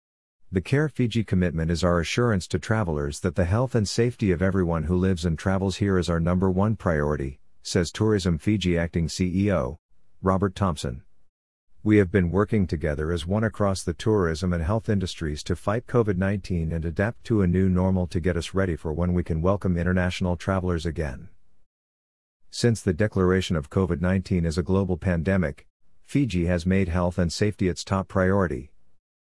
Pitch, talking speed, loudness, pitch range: 90 Hz, 180 wpm, -25 LUFS, 85-100 Hz